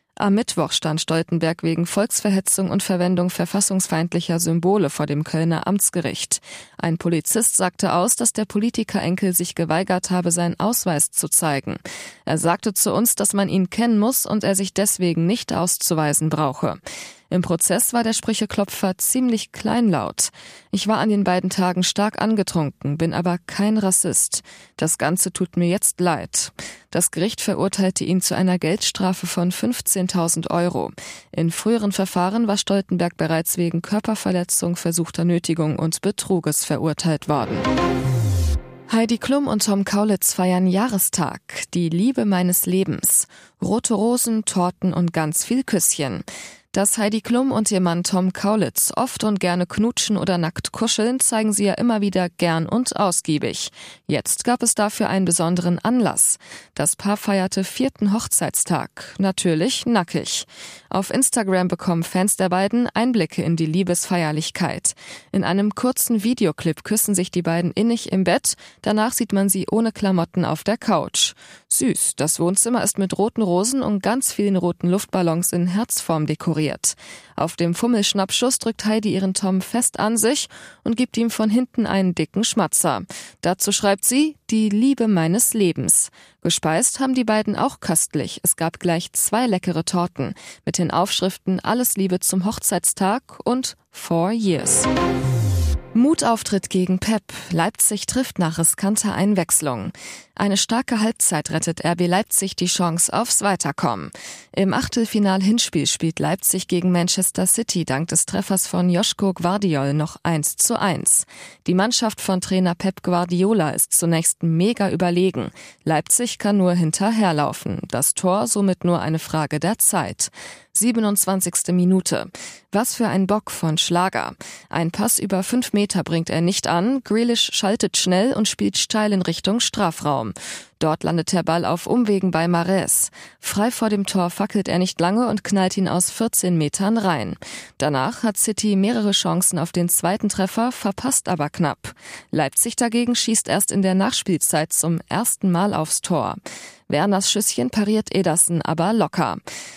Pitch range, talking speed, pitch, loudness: 170-215 Hz, 150 wpm, 190 Hz, -20 LUFS